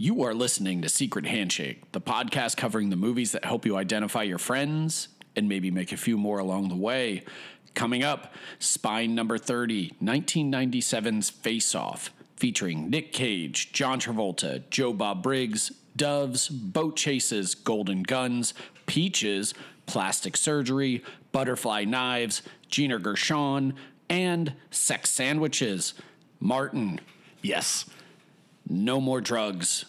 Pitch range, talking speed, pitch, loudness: 110-145 Hz, 125 wpm, 125 Hz, -27 LUFS